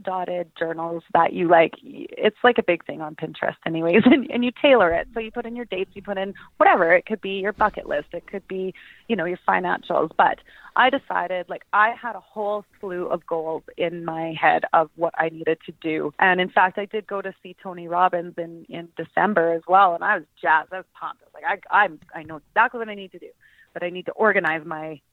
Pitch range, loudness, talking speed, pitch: 165-210 Hz, -22 LUFS, 240 wpm, 180 Hz